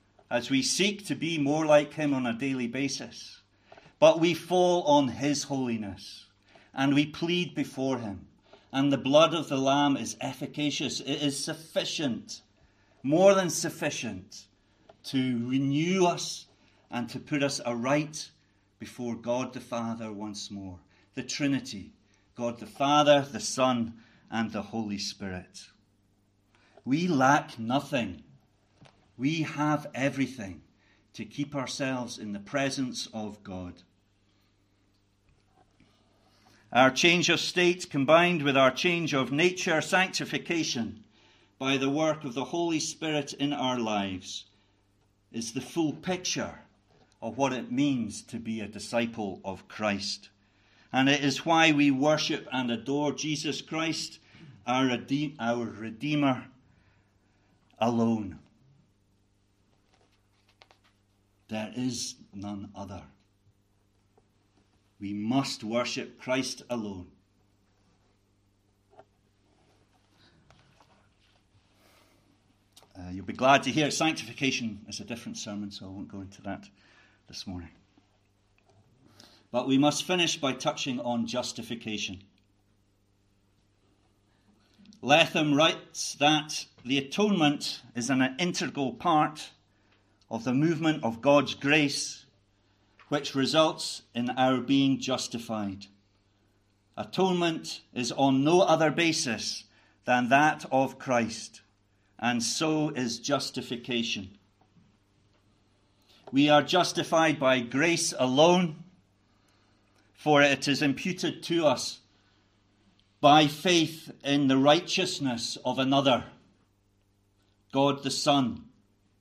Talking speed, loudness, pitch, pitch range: 110 wpm, -27 LUFS, 120 Hz, 100-145 Hz